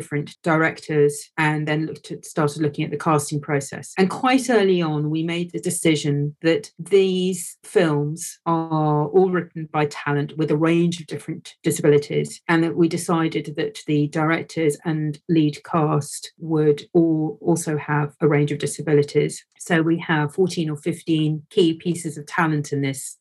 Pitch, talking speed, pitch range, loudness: 155 Hz, 165 wpm, 150-165 Hz, -21 LUFS